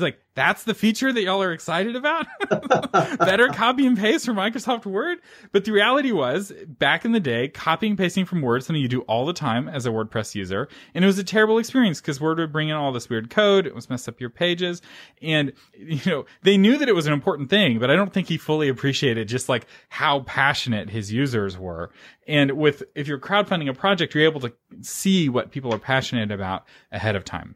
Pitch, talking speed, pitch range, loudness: 155 Hz, 225 wpm, 125-200 Hz, -22 LUFS